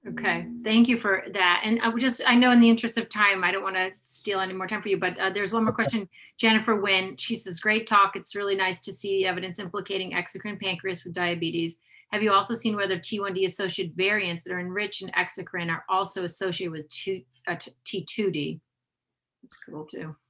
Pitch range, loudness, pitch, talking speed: 180-210 Hz, -25 LUFS, 195 Hz, 215 wpm